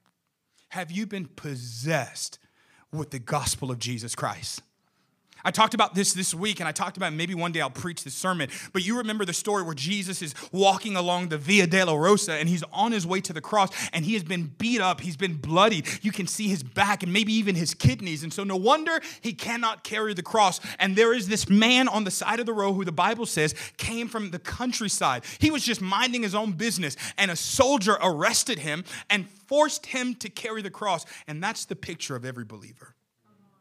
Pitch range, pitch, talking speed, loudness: 165-215 Hz, 190 Hz, 220 wpm, -25 LUFS